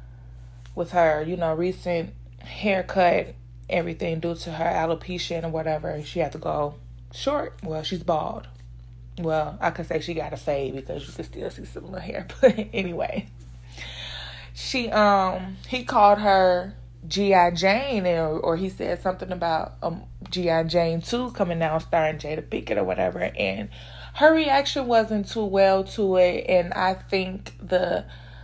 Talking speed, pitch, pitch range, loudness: 160 wpm, 170 Hz, 150-185 Hz, -24 LUFS